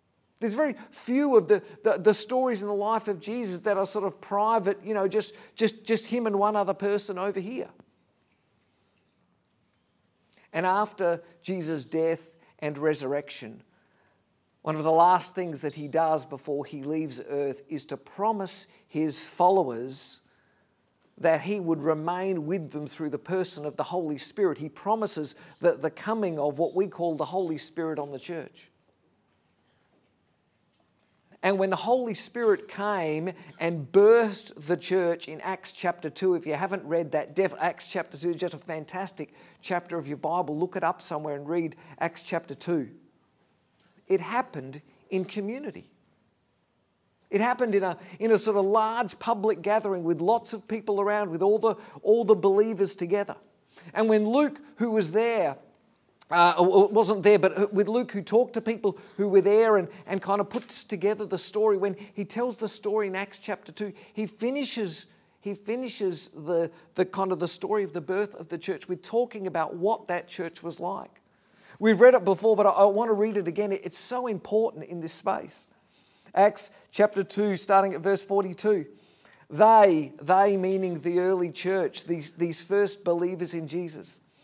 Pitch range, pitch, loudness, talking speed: 170-210 Hz, 195 Hz, -27 LUFS, 175 wpm